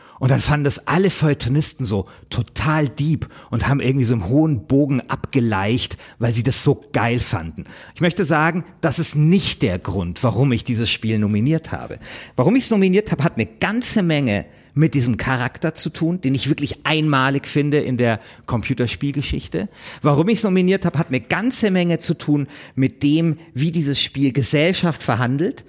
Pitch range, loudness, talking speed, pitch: 120-165 Hz, -19 LUFS, 180 wpm, 140 Hz